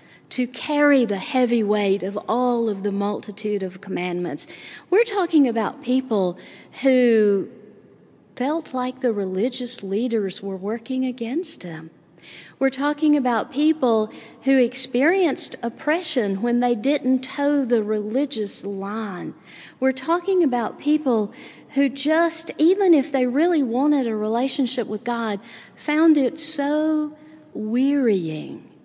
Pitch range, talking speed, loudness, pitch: 215-285 Hz, 125 wpm, -21 LUFS, 250 Hz